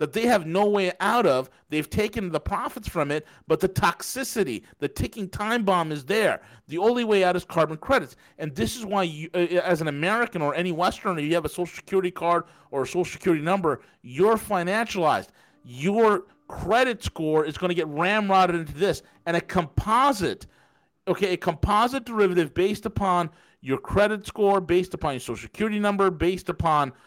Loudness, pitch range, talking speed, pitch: -24 LUFS, 155-200 Hz, 185 wpm, 180 Hz